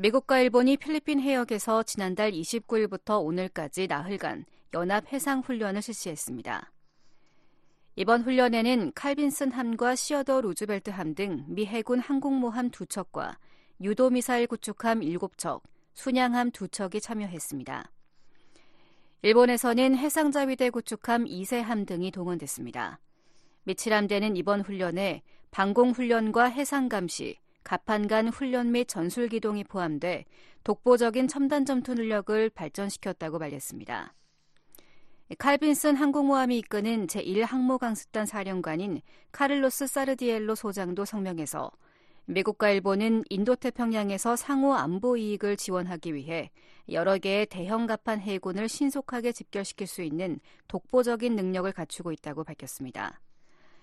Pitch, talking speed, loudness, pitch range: 220 Hz, 305 characters per minute, -28 LUFS, 195-250 Hz